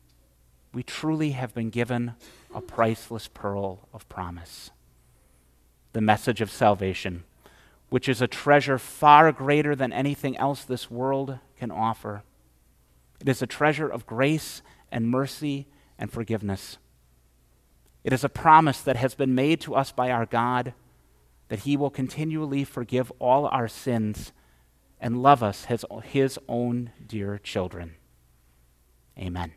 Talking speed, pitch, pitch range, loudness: 135 wpm, 115 Hz, 85-135 Hz, -25 LUFS